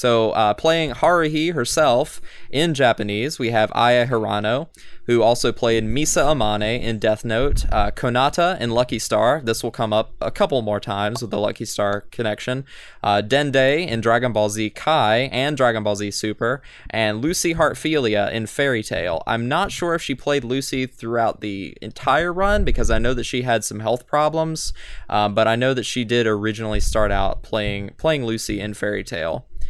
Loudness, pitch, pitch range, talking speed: -20 LUFS, 115 Hz, 110-135 Hz, 185 wpm